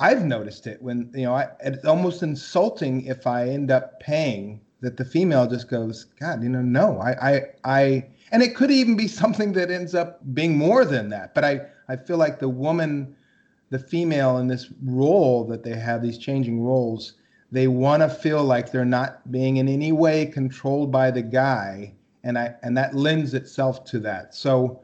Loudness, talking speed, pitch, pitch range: -22 LUFS, 200 wpm, 130 Hz, 125-150 Hz